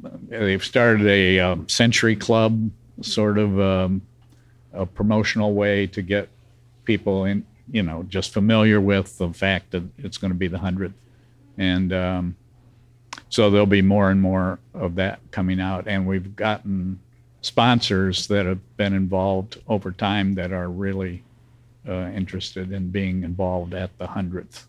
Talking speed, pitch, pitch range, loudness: 155 wpm, 100 Hz, 95-110 Hz, -22 LUFS